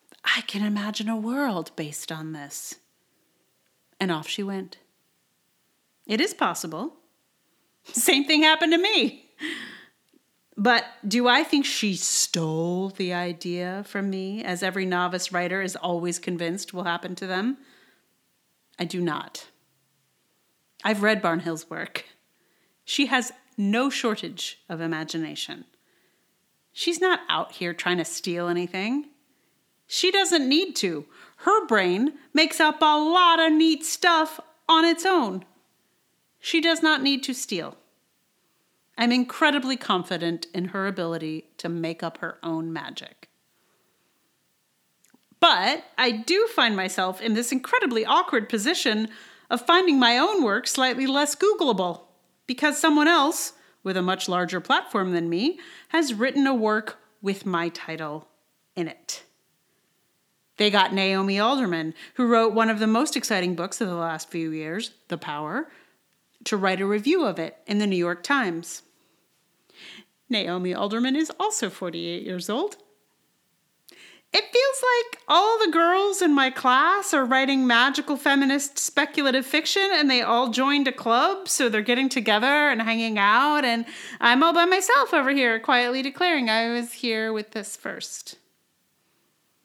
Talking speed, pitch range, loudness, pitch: 145 wpm, 180-300 Hz, -23 LUFS, 235 Hz